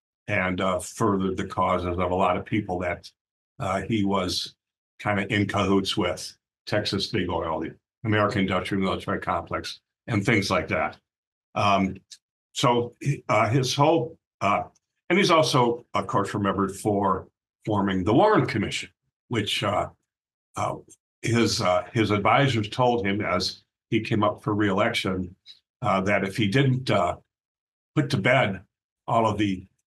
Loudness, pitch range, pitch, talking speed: -25 LUFS, 95-115 Hz, 100 Hz, 150 wpm